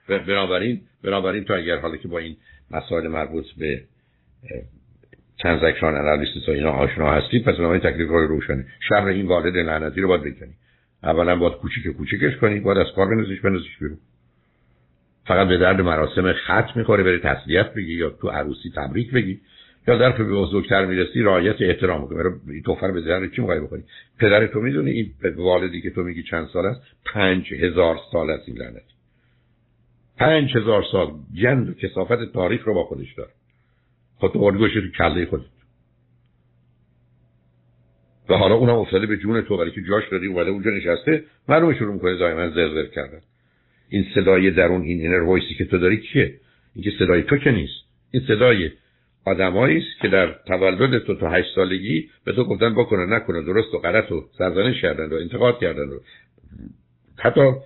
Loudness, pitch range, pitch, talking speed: -20 LUFS, 80-105 Hz, 95 Hz, 170 wpm